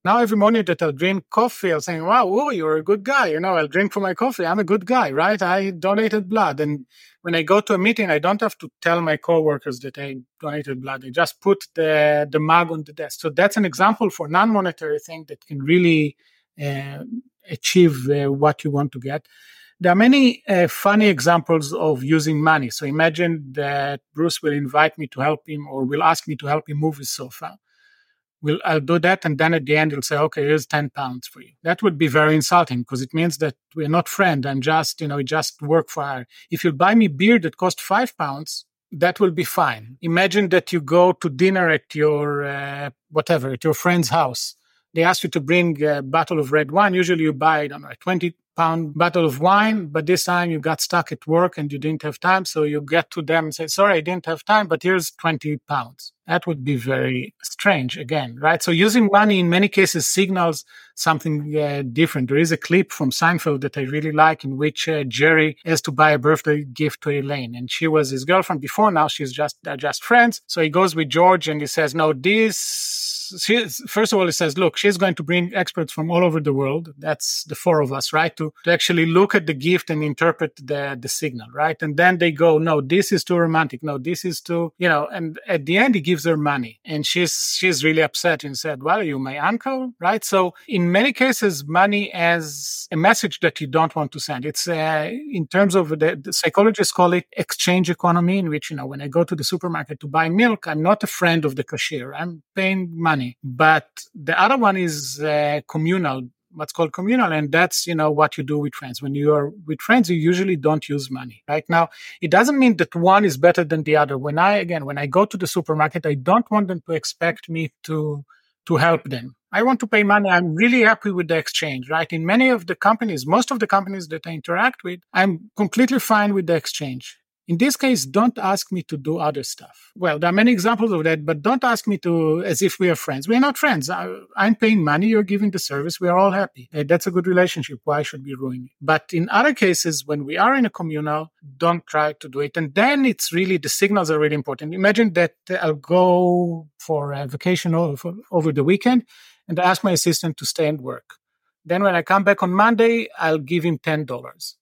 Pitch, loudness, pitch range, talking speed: 165 Hz, -19 LUFS, 150-185 Hz, 235 wpm